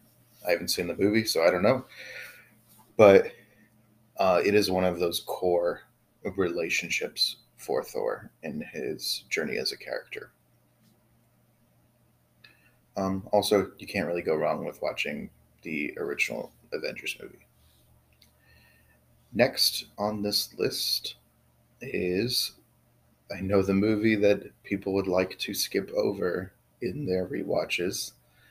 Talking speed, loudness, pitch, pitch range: 120 wpm, -27 LUFS, 95 Hz, 85-105 Hz